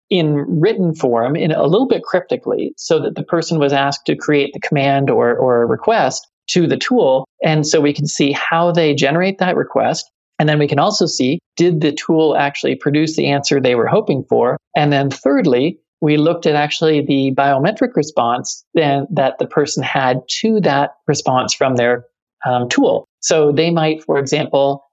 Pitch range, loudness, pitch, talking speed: 140-160 Hz, -15 LUFS, 145 Hz, 190 wpm